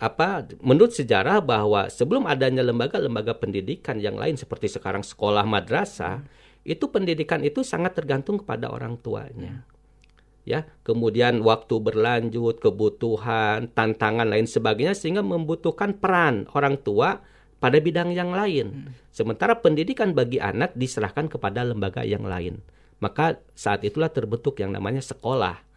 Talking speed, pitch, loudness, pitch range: 130 wpm, 125 Hz, -24 LUFS, 110-155 Hz